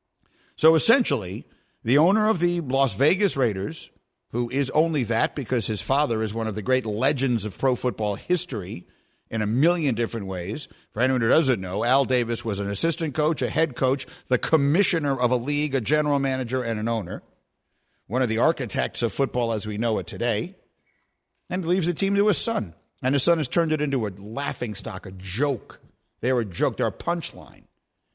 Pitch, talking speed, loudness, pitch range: 130 Hz, 195 wpm, -24 LUFS, 115-155 Hz